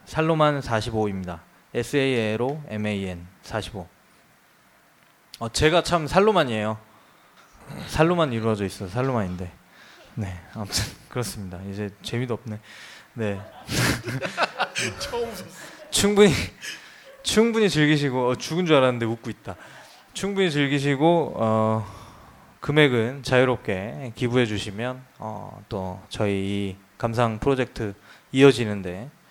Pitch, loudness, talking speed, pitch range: 115 Hz, -24 LUFS, 230 characters per minute, 105-145 Hz